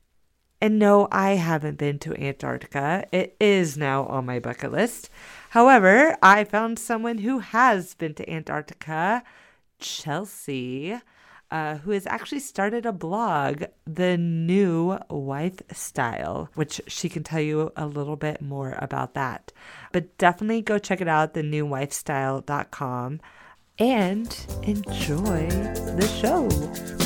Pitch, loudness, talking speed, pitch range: 170 Hz, -24 LUFS, 125 wpm, 145-205 Hz